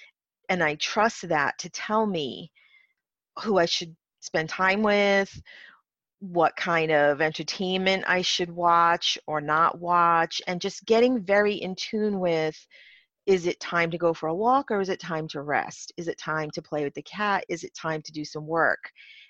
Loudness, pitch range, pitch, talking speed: -25 LUFS, 160-200 Hz, 175 Hz, 185 wpm